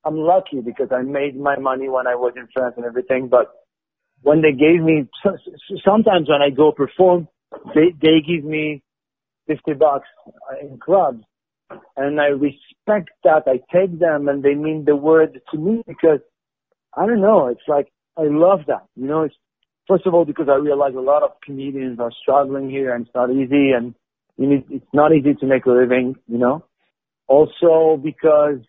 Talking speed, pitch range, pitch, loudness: 185 wpm, 130-160 Hz, 145 Hz, -17 LUFS